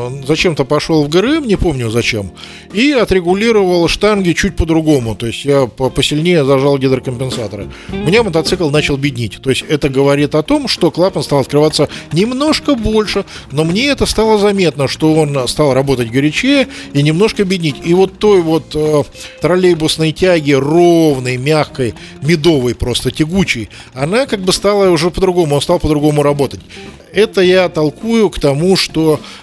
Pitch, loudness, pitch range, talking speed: 155 Hz, -12 LUFS, 140-185 Hz, 155 wpm